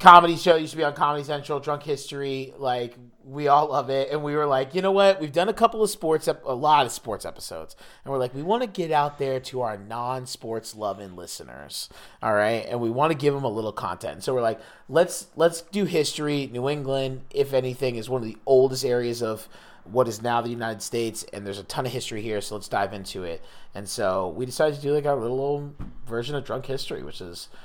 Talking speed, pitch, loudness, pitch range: 240 wpm, 135 Hz, -25 LUFS, 120-150 Hz